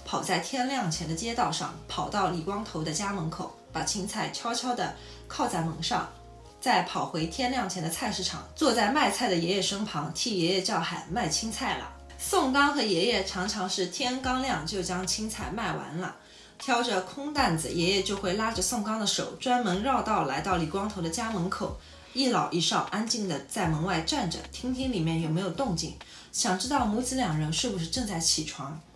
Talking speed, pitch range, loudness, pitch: 285 characters per minute, 175-240 Hz, -29 LUFS, 195 Hz